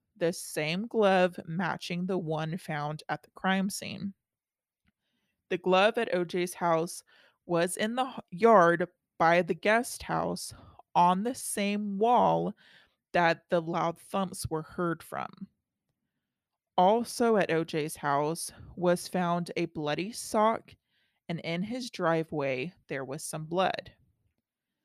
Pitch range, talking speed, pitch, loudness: 165-195 Hz, 125 wpm, 180 Hz, -29 LUFS